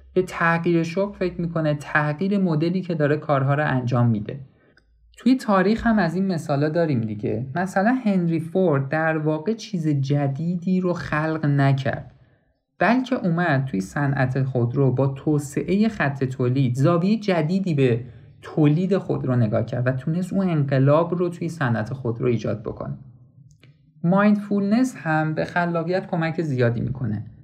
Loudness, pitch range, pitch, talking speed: -22 LUFS, 135-180 Hz, 155 Hz, 145 wpm